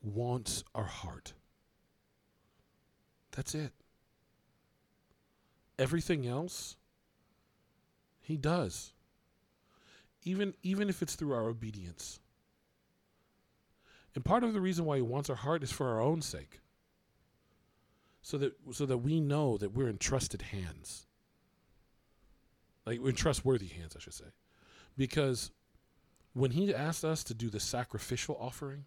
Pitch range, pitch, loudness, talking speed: 110-155 Hz, 135 Hz, -35 LUFS, 125 wpm